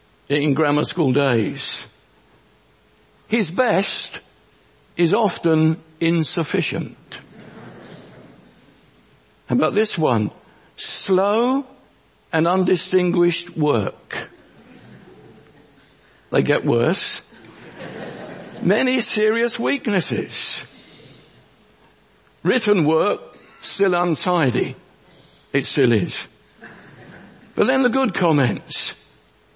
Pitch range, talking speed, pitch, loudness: 160-215 Hz, 70 wpm, 180 Hz, -20 LUFS